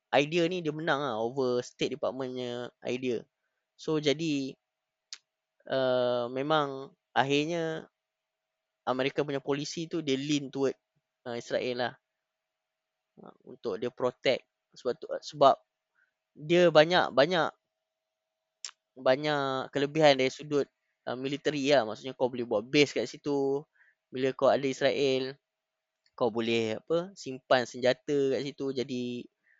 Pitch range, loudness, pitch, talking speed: 115-140 Hz, -29 LUFS, 130 Hz, 120 wpm